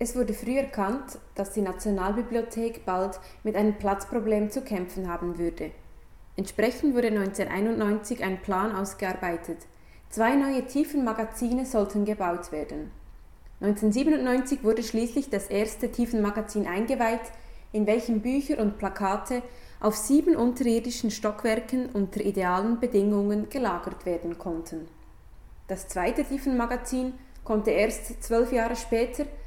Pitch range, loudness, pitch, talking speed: 195-240 Hz, -28 LUFS, 215 Hz, 115 wpm